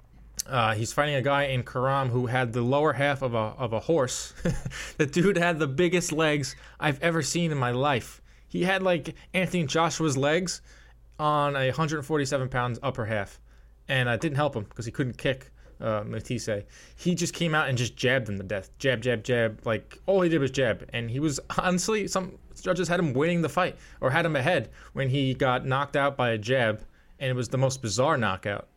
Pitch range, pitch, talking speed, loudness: 120-160 Hz, 135 Hz, 215 wpm, -27 LUFS